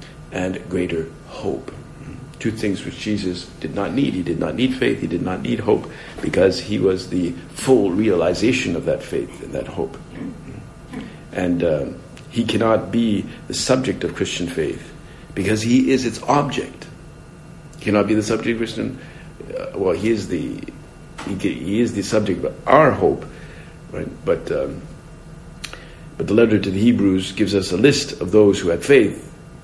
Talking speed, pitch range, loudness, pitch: 170 wpm, 95-130 Hz, -20 LUFS, 110 Hz